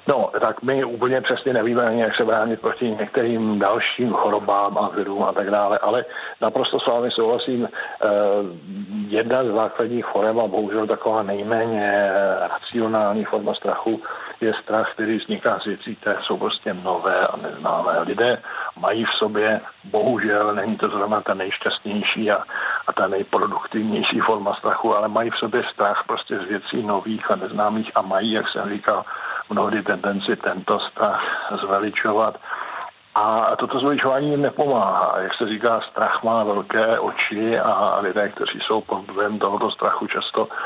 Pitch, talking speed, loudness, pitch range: 110 Hz, 155 wpm, -21 LUFS, 105-120 Hz